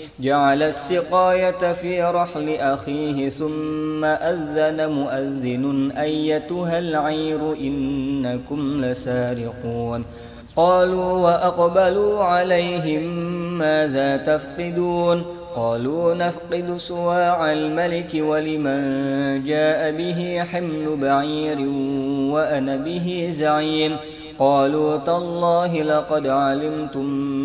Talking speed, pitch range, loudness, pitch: 70 wpm, 140-175 Hz, -21 LUFS, 155 Hz